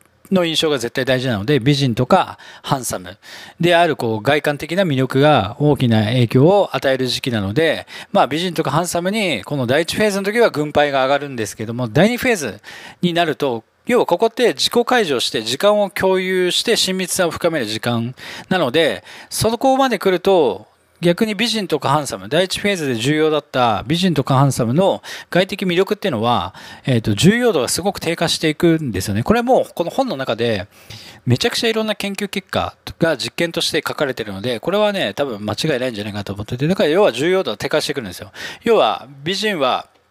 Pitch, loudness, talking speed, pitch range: 155 Hz, -17 LUFS, 405 characters per minute, 130-190 Hz